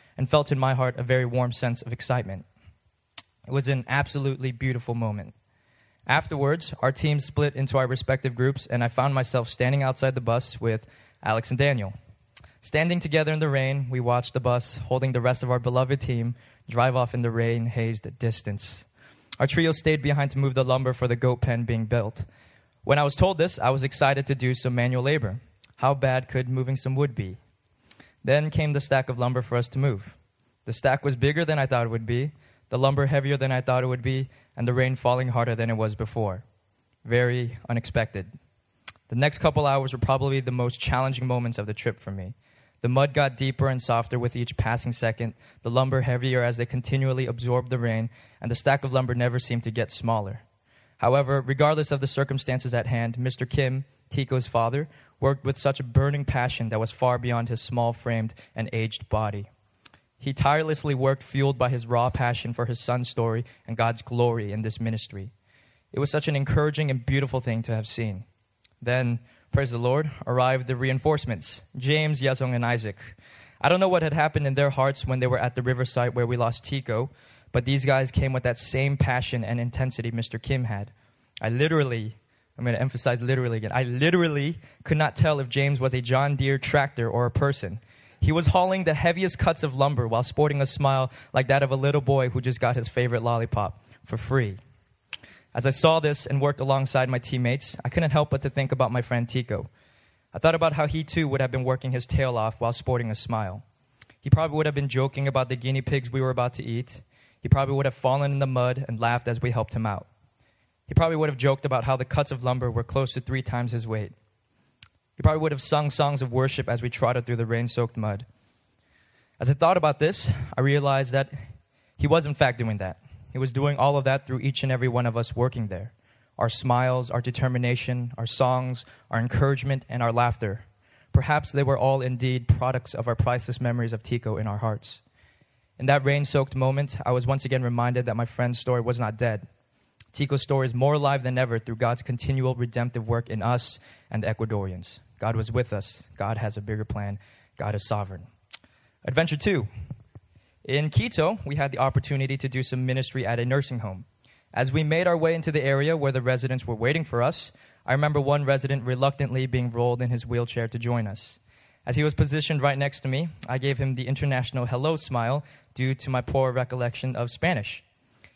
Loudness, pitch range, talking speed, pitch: -26 LUFS, 115-135 Hz, 210 wpm, 125 Hz